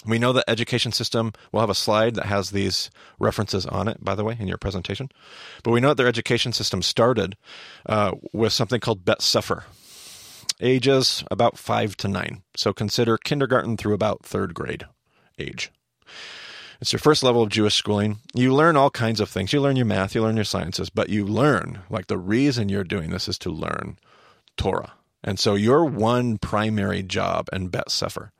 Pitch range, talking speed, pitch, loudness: 100-120 Hz, 190 wpm, 110 Hz, -22 LUFS